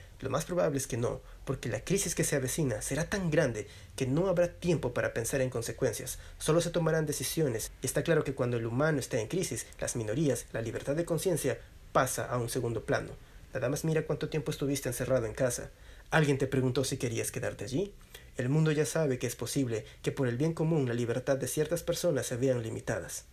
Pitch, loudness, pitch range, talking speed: 135 Hz, -32 LUFS, 125-155 Hz, 215 wpm